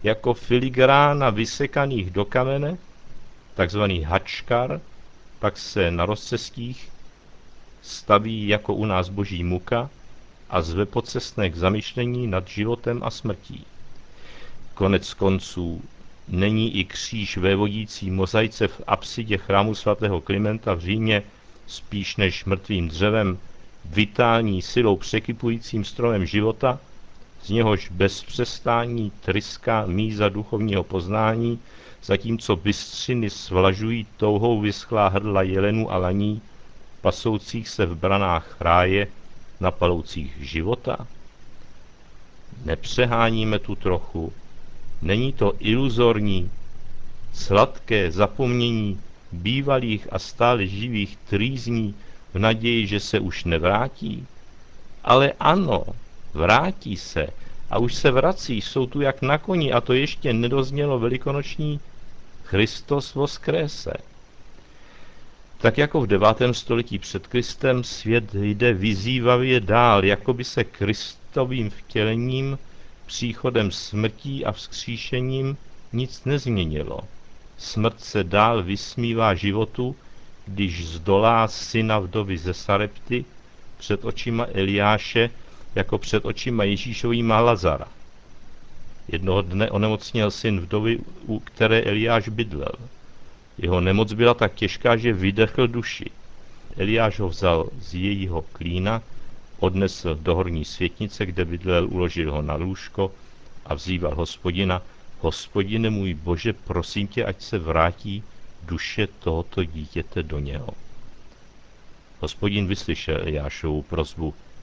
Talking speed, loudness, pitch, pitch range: 110 wpm, -23 LUFS, 105 Hz, 95-115 Hz